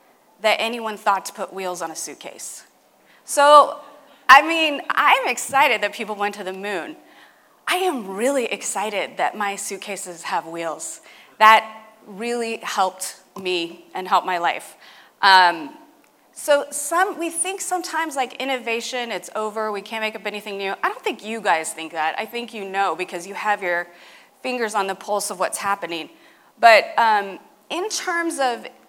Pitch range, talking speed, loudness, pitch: 195-285 Hz, 165 wpm, -20 LUFS, 220 Hz